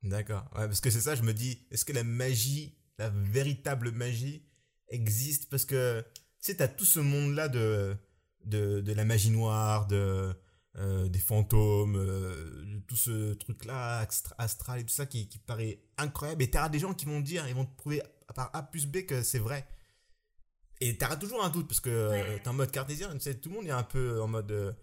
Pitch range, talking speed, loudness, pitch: 105-140 Hz, 215 wpm, -32 LUFS, 120 Hz